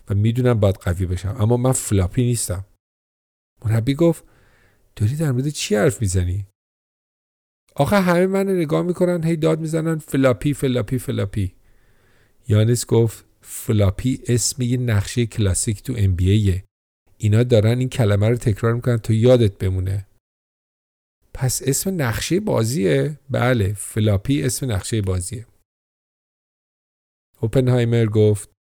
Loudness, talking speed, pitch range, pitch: -20 LUFS, 125 wpm, 100-130 Hz, 115 Hz